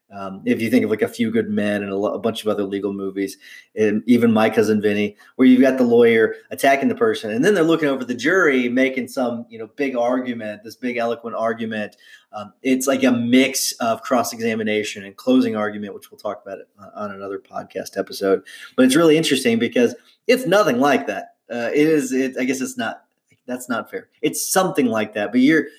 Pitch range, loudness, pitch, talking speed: 105-160 Hz, -19 LUFS, 125 Hz, 210 wpm